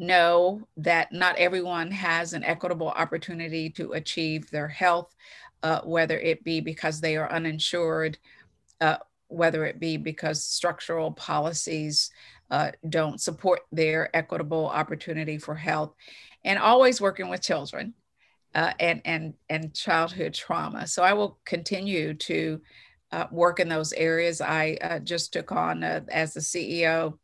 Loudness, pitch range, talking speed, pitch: -26 LUFS, 155-175 Hz, 145 wpm, 165 Hz